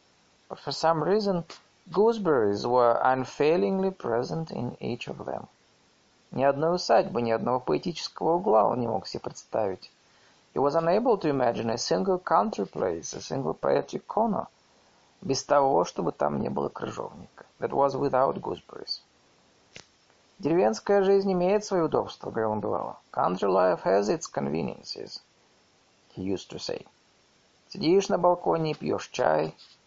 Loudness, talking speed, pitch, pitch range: -27 LUFS, 140 wpm, 160 Hz, 120-190 Hz